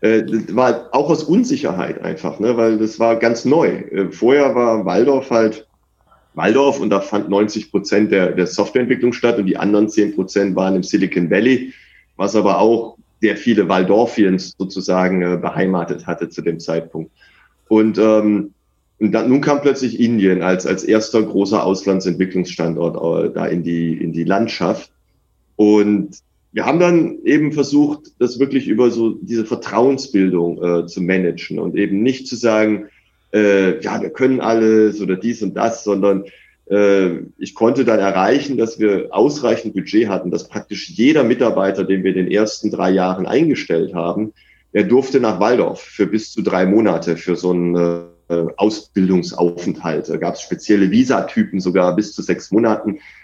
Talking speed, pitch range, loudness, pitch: 160 wpm, 95-115 Hz, -16 LUFS, 105 Hz